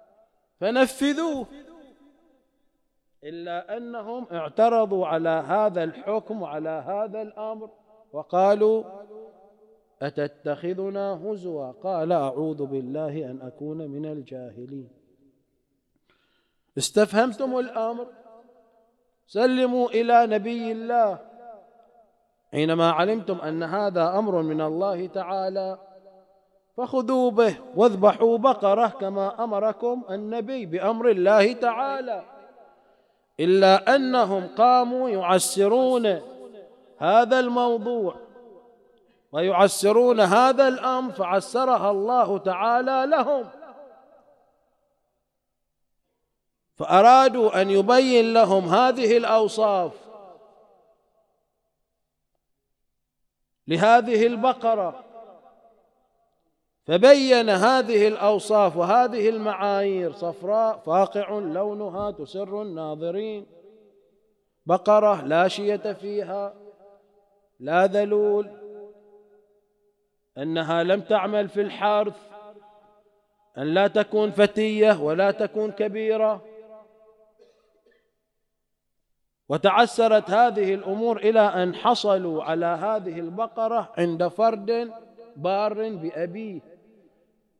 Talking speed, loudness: 75 wpm, -22 LUFS